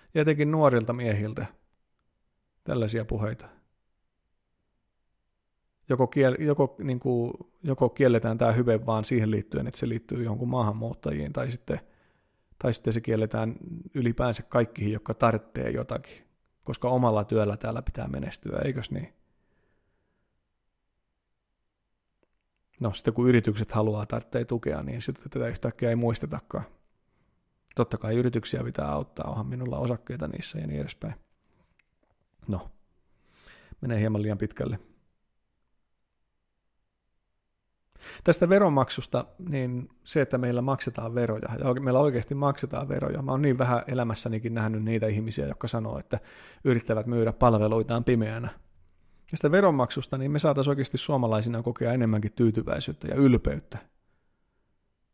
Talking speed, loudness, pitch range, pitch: 120 wpm, -28 LUFS, 110-130 Hz, 120 Hz